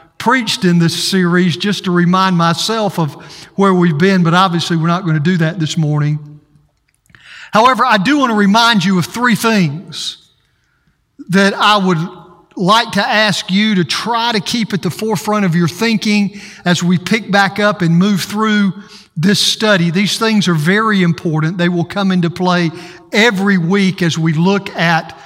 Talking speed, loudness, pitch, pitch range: 180 wpm, -13 LUFS, 185 Hz, 170-205 Hz